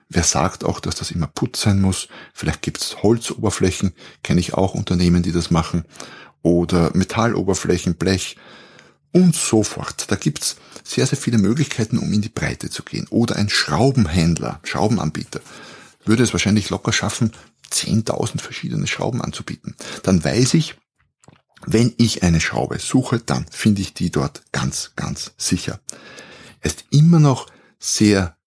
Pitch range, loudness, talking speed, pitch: 85-120 Hz, -19 LUFS, 155 wpm, 105 Hz